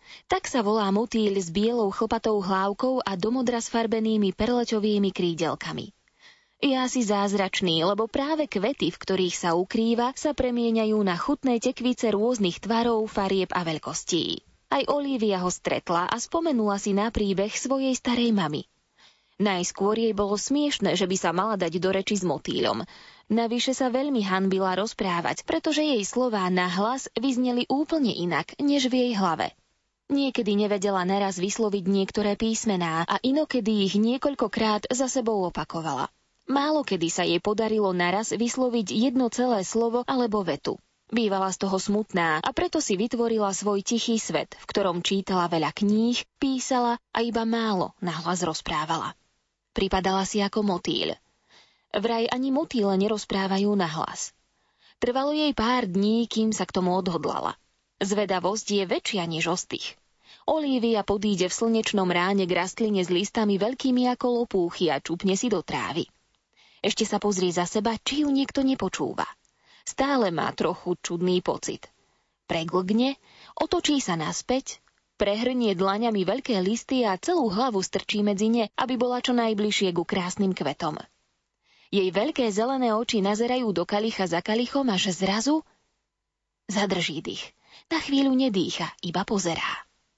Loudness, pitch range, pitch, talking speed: -25 LUFS, 190-245 Hz, 215 Hz, 145 wpm